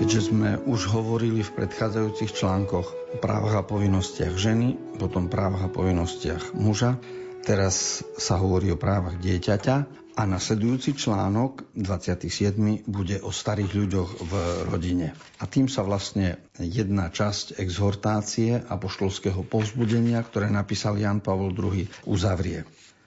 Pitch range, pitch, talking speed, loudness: 95-110 Hz, 100 Hz, 125 wpm, -26 LUFS